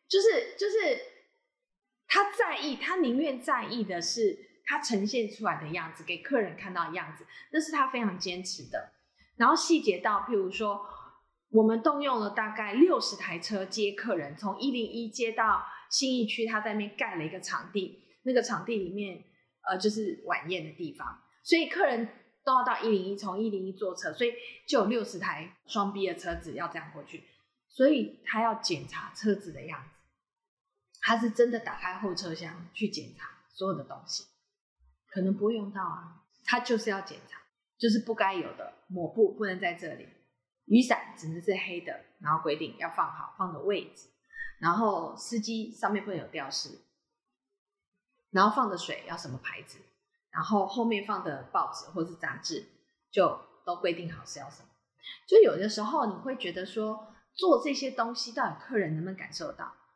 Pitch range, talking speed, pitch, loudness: 185-255 Hz, 265 characters per minute, 215 Hz, -30 LUFS